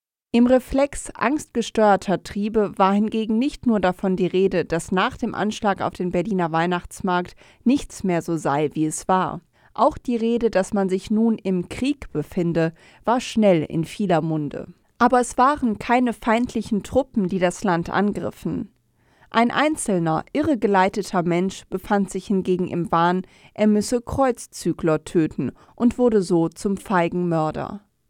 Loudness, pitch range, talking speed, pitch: -22 LUFS, 175-230 Hz, 150 wpm, 195 Hz